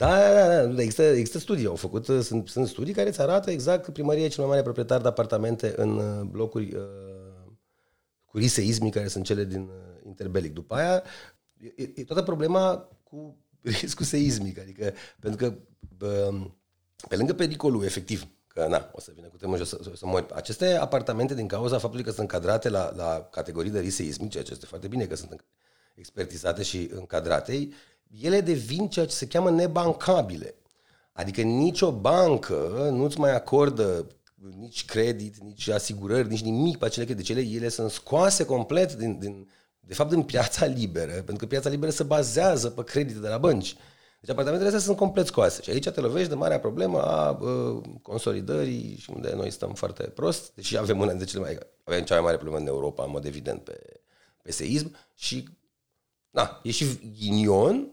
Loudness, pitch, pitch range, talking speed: -26 LUFS, 115 Hz, 100-150 Hz, 180 wpm